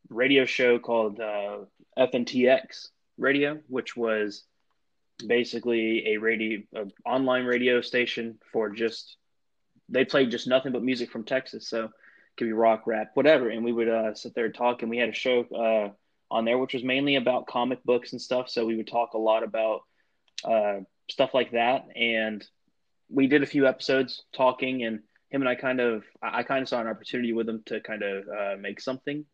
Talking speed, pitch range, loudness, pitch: 195 wpm, 110-130 Hz, -26 LUFS, 120 Hz